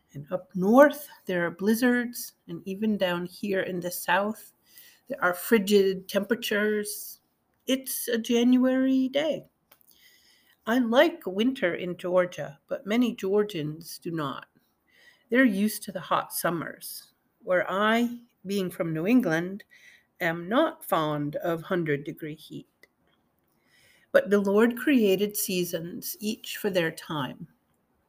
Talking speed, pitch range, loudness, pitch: 125 wpm, 180-240 Hz, -26 LUFS, 205 Hz